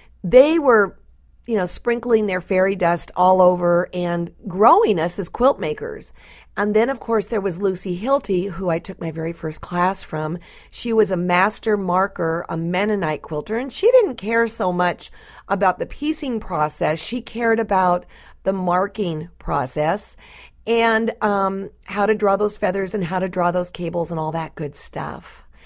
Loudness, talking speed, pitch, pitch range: -20 LUFS, 175 wpm, 190 Hz, 175-220 Hz